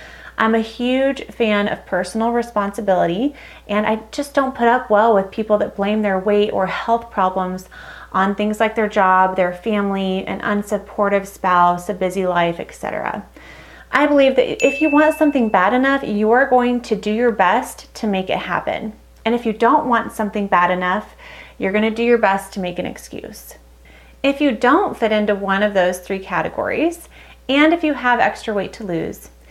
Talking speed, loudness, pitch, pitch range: 190 wpm, -18 LUFS, 210 Hz, 190-240 Hz